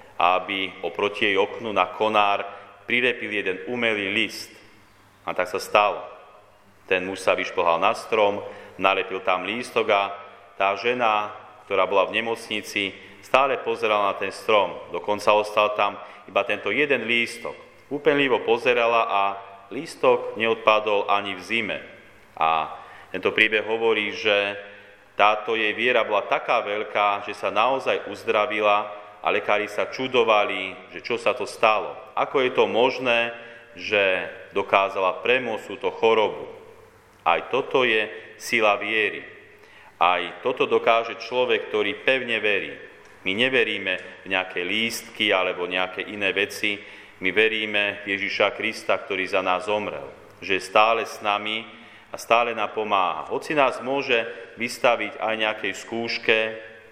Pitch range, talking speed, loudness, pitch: 100-120 Hz, 135 wpm, -23 LUFS, 105 Hz